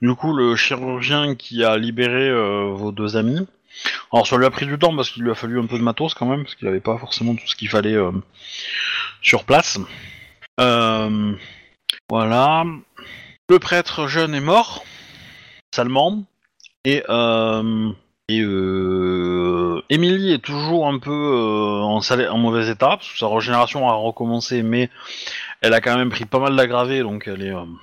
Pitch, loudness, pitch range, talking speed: 120 Hz, -19 LUFS, 110-135 Hz, 180 wpm